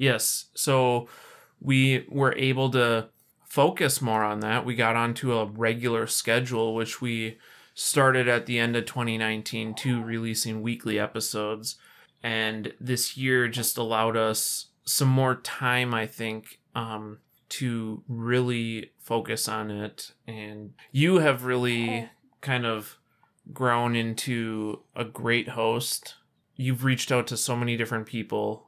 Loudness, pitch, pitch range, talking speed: -26 LUFS, 115 Hz, 110-125 Hz, 135 wpm